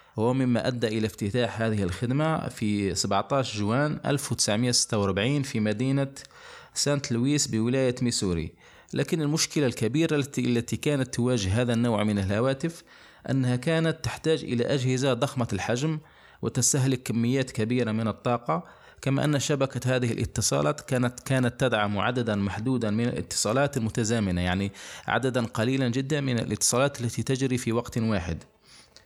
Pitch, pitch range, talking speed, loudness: 125 Hz, 110-135 Hz, 130 wpm, -26 LUFS